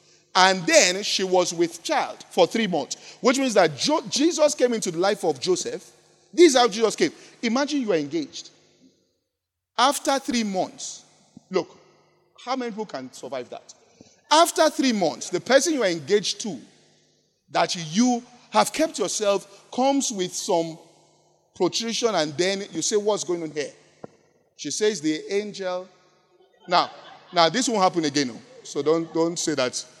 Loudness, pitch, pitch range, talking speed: -23 LUFS, 200 Hz, 175-250 Hz, 160 wpm